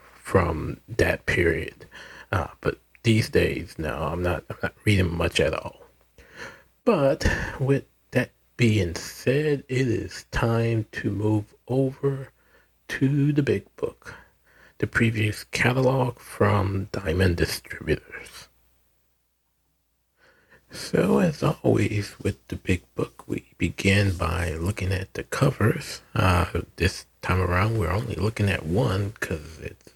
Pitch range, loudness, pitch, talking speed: 85-115 Hz, -25 LUFS, 100 Hz, 125 wpm